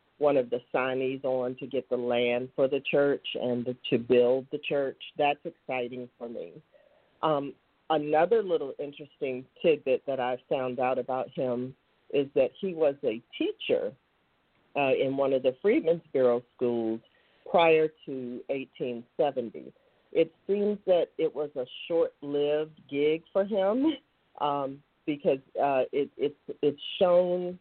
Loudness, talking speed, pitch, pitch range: -29 LUFS, 145 wpm, 145 Hz, 130-195 Hz